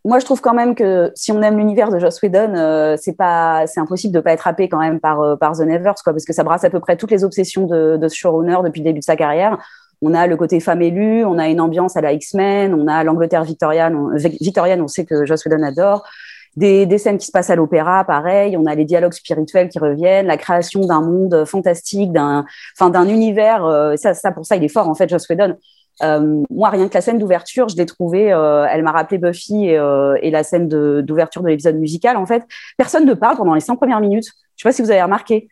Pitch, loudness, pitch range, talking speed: 175 Hz, -15 LUFS, 160-200 Hz, 260 wpm